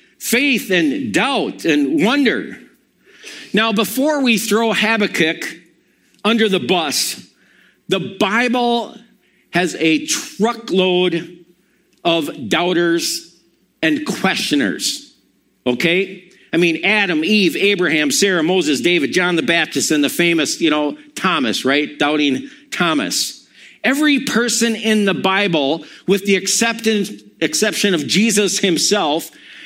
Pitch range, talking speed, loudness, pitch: 170-230 Hz, 110 wpm, -16 LUFS, 195 Hz